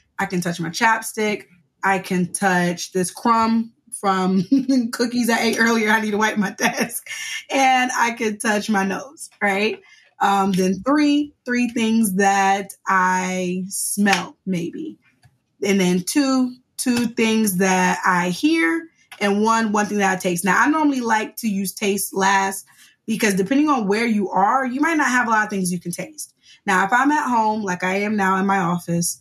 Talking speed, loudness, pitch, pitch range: 185 wpm, -20 LUFS, 210 Hz, 185-245 Hz